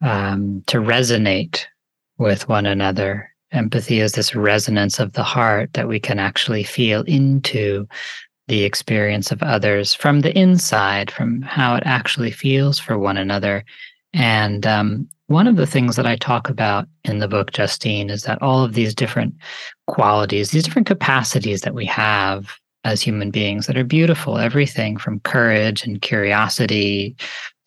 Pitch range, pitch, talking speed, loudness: 105-130 Hz, 110 Hz, 155 wpm, -18 LUFS